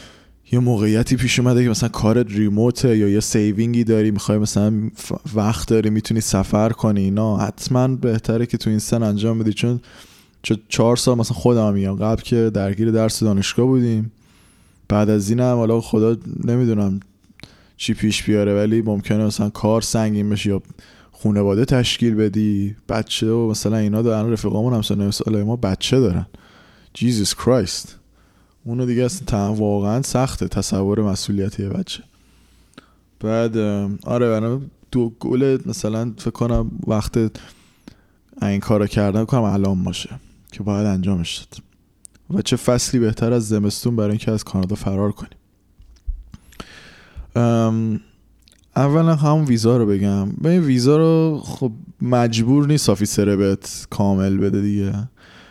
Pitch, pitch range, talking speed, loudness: 110 Hz, 100-120 Hz, 140 wpm, -19 LUFS